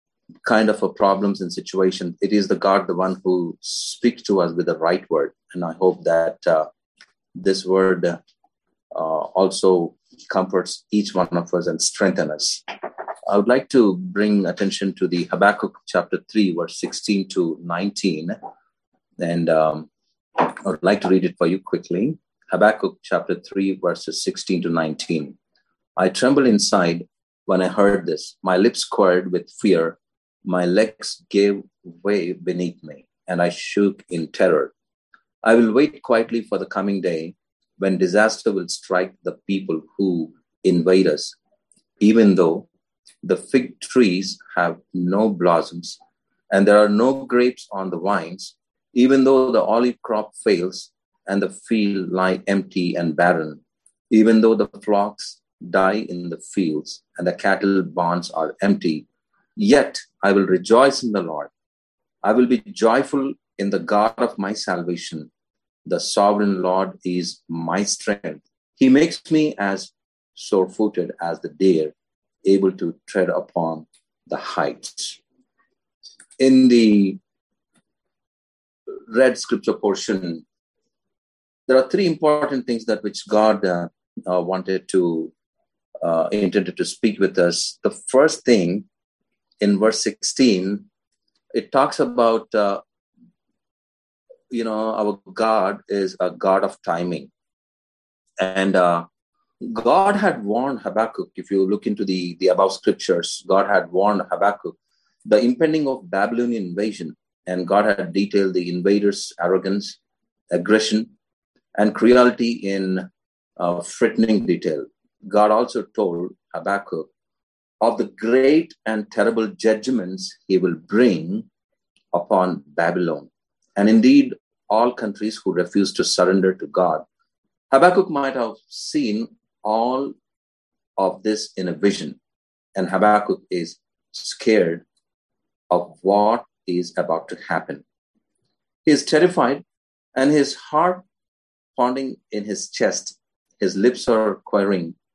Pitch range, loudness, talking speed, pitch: 90-110 Hz, -20 LUFS, 135 wpm, 100 Hz